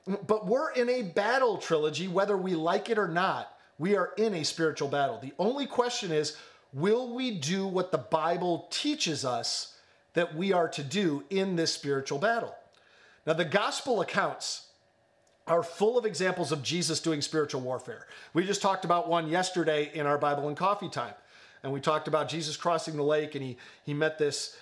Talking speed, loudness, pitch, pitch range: 190 wpm, -29 LUFS, 170 Hz, 150-195 Hz